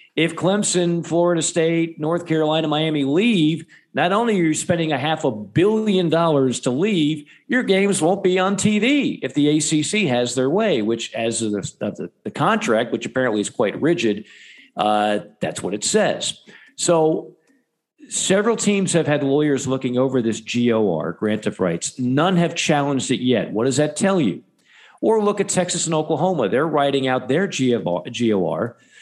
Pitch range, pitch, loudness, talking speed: 130-185 Hz, 155 Hz, -20 LUFS, 170 wpm